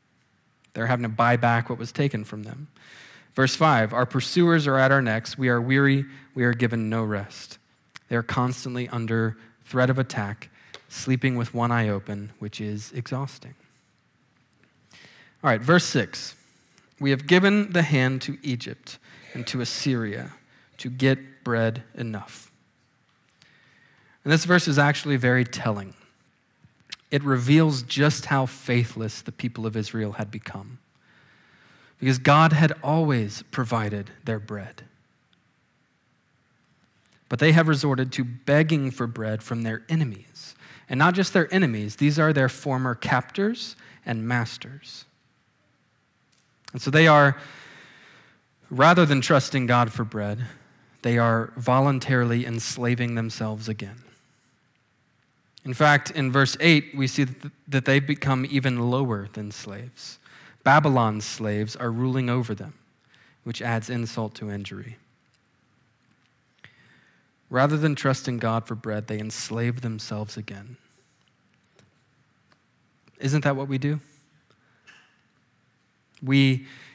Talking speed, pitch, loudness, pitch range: 125 wpm, 125 Hz, -23 LUFS, 115-140 Hz